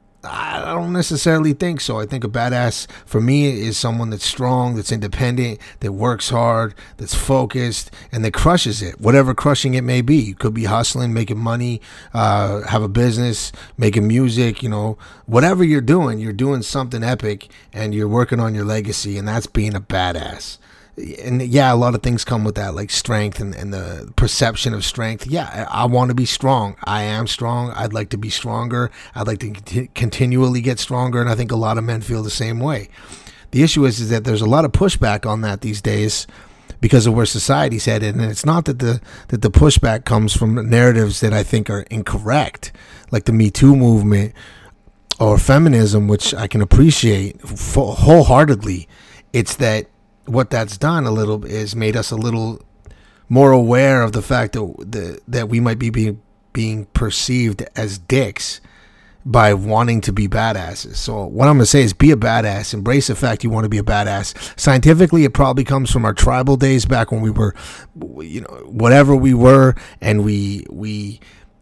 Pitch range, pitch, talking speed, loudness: 105-125 Hz, 115 Hz, 195 wpm, -16 LUFS